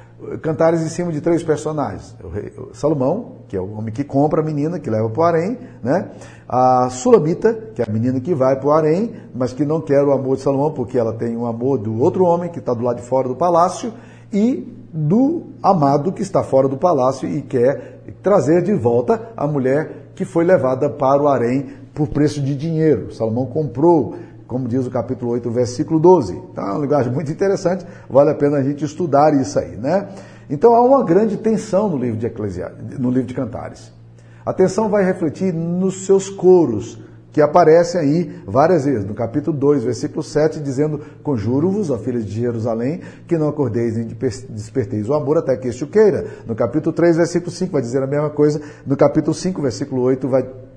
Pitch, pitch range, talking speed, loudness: 145 Hz, 125-170 Hz, 205 wpm, -18 LUFS